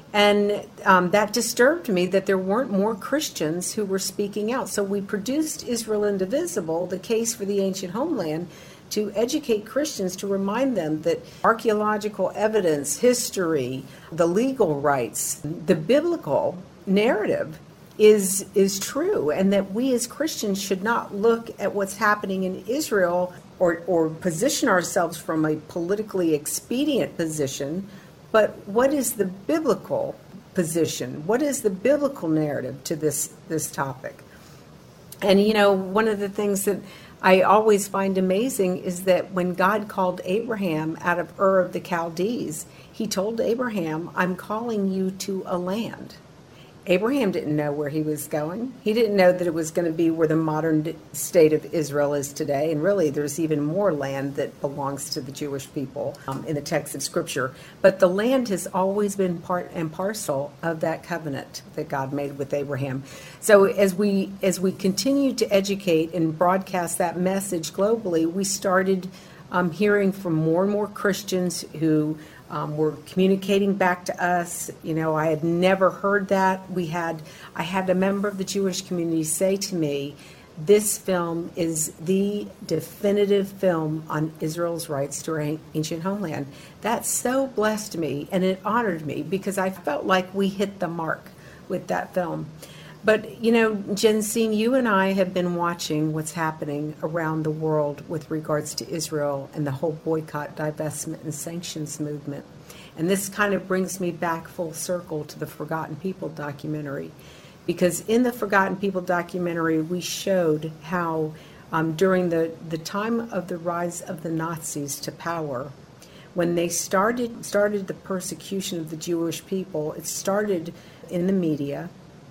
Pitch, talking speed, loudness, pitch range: 180 Hz, 160 wpm, -24 LUFS, 160-200 Hz